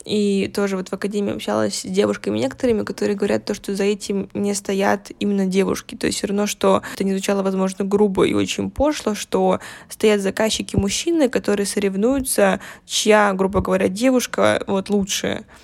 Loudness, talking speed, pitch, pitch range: -20 LUFS, 170 wpm, 200 Hz, 195-210 Hz